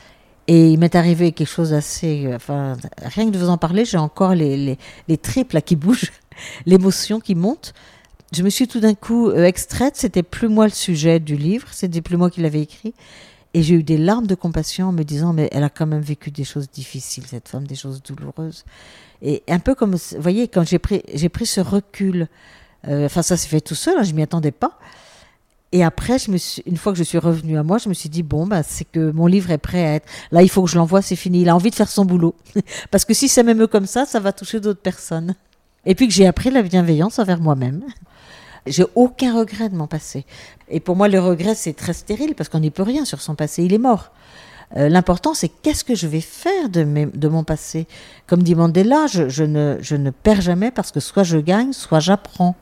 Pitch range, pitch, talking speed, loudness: 155-200 Hz, 175 Hz, 240 wpm, -18 LUFS